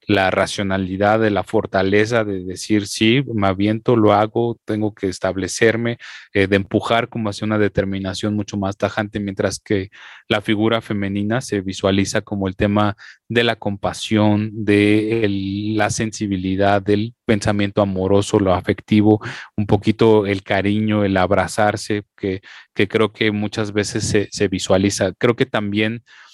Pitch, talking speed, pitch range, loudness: 105 Hz, 150 wpm, 100-110 Hz, -19 LUFS